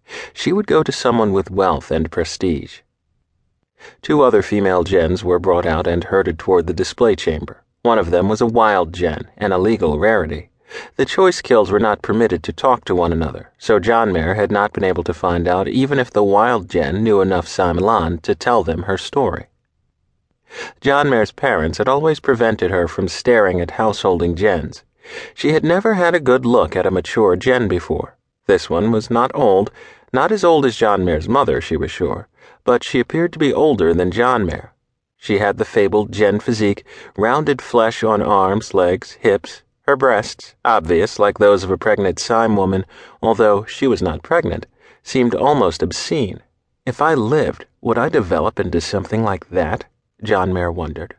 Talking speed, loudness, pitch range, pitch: 185 wpm, -17 LUFS, 90-115 Hz, 100 Hz